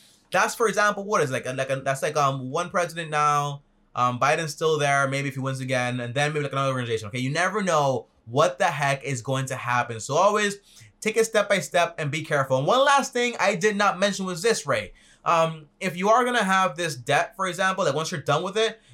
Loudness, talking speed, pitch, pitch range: -24 LUFS, 255 wpm, 155 Hz, 135-195 Hz